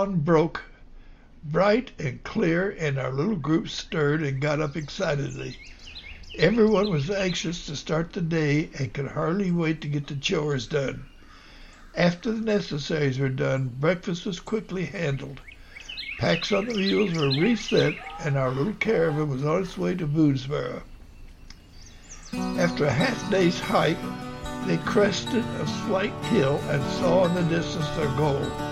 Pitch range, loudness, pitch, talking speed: 135-180 Hz, -25 LUFS, 155 Hz, 150 wpm